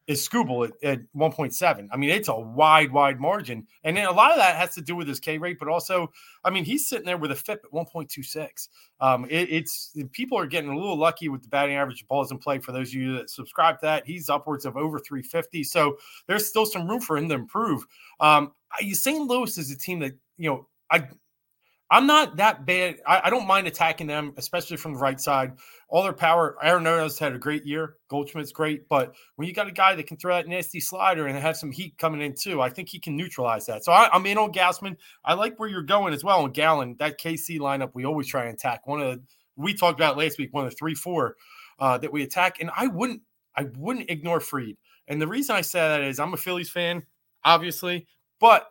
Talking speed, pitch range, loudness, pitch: 245 wpm, 140-180 Hz, -24 LUFS, 160 Hz